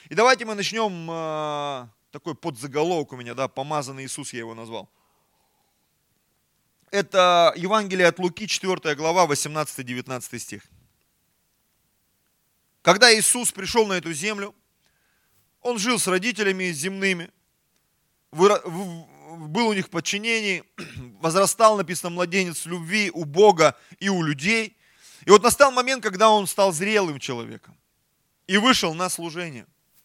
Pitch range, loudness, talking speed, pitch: 150-205 Hz, -21 LUFS, 120 wpm, 180 Hz